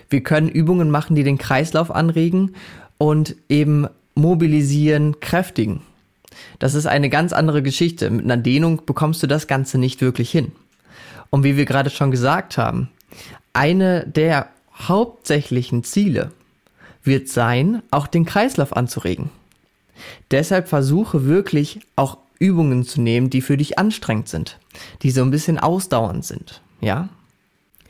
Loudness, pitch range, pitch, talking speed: -18 LUFS, 130-165 Hz, 145 Hz, 140 wpm